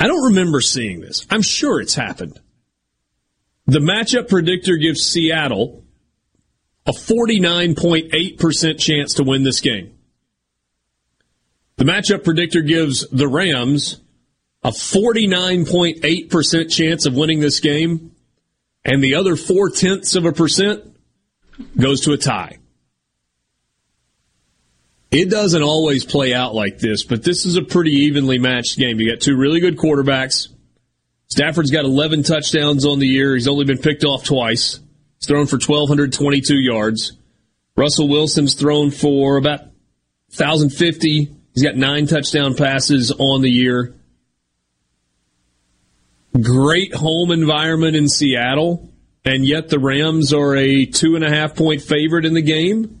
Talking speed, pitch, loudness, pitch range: 135 wpm, 145 Hz, -16 LUFS, 125-160 Hz